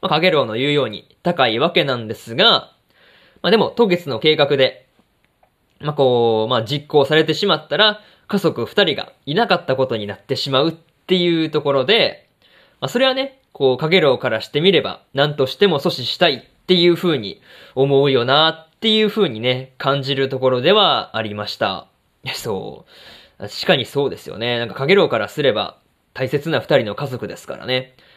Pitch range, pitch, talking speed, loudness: 130-175 Hz, 140 Hz, 360 characters per minute, -17 LUFS